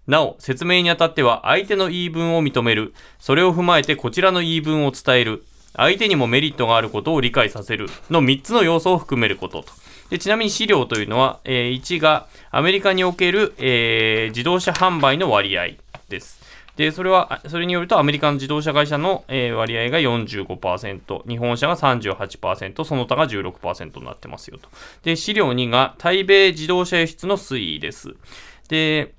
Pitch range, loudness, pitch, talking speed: 125-180 Hz, -18 LUFS, 155 Hz, 325 characters per minute